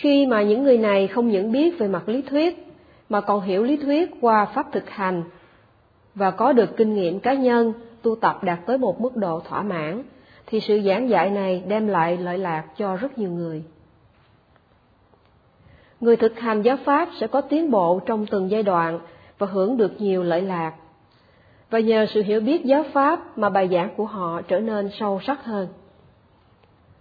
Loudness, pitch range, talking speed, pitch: -22 LUFS, 180-240 Hz, 190 wpm, 205 Hz